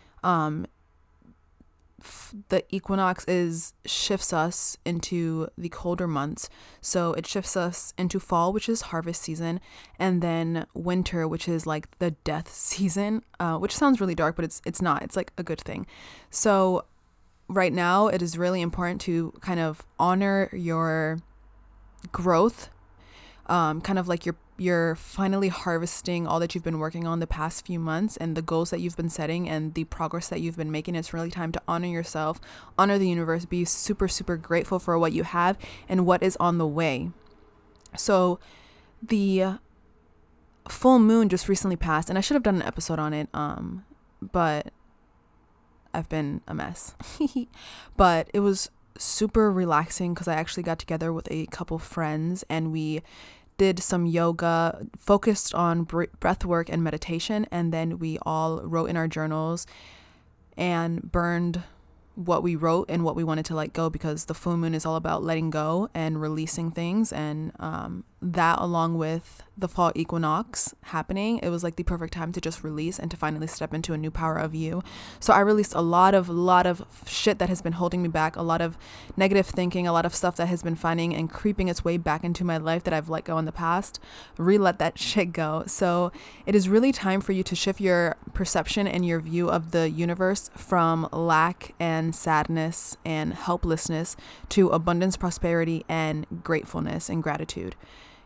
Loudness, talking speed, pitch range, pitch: -26 LUFS, 180 wpm, 160-180 Hz, 170 Hz